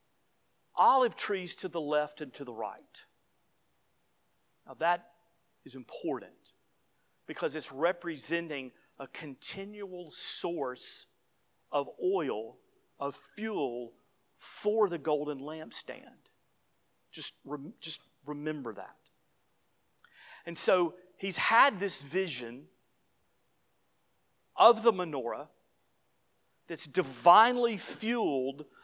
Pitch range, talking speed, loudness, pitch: 150-195 Hz, 90 wpm, -31 LUFS, 170 Hz